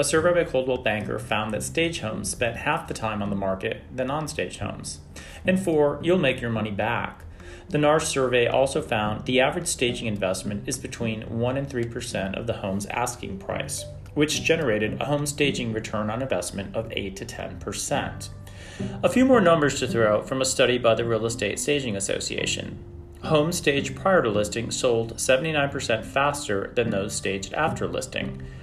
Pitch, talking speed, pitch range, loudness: 115 Hz, 185 wpm, 100-140 Hz, -25 LUFS